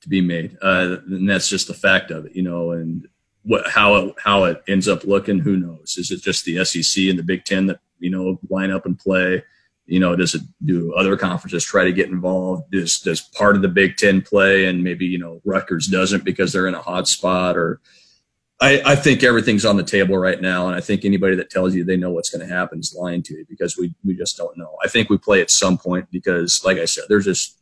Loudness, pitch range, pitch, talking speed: -18 LUFS, 90-95 Hz, 95 Hz, 255 wpm